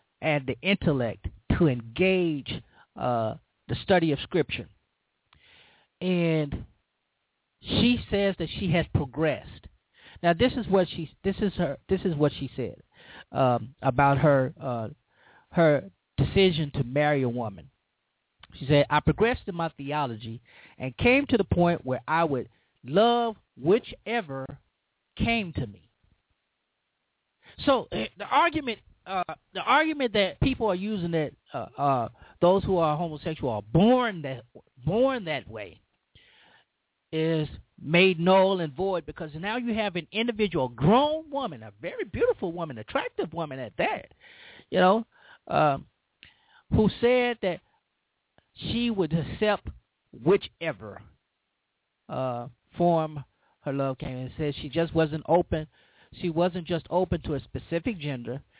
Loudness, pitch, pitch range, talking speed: -27 LUFS, 165 Hz, 135-195 Hz, 135 wpm